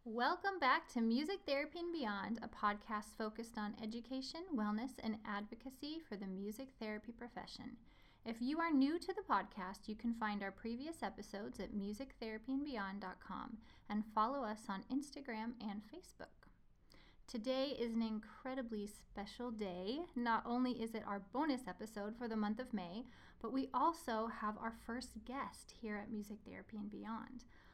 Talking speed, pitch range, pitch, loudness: 160 wpm, 210-260 Hz, 230 Hz, -43 LUFS